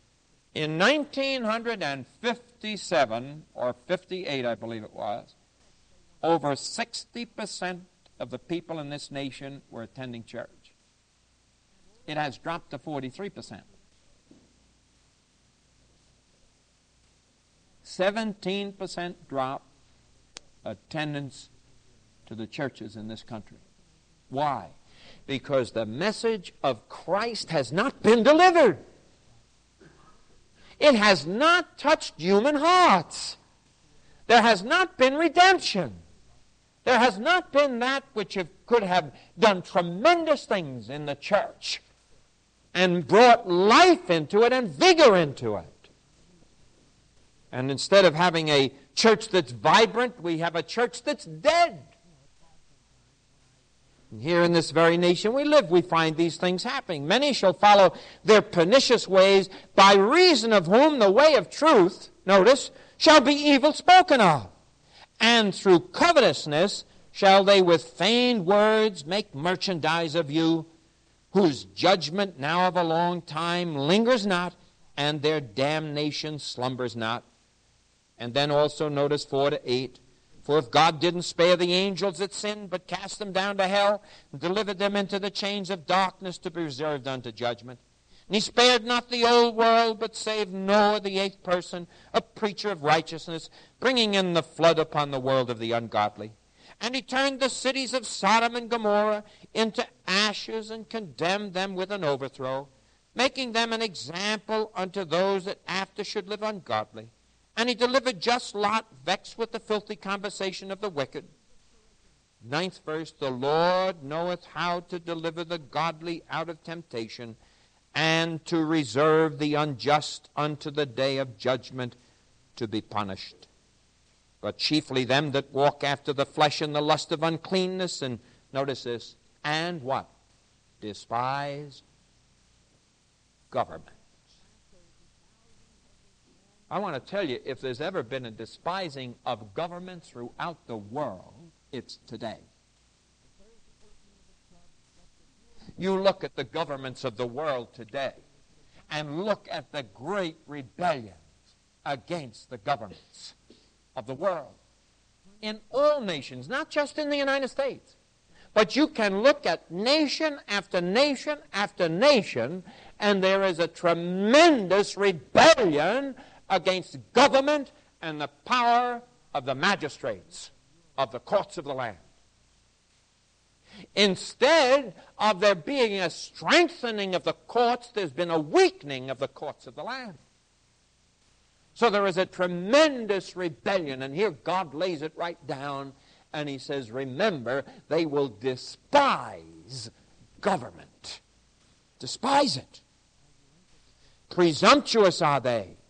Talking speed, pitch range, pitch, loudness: 130 wpm, 140-215 Hz, 175 Hz, -24 LUFS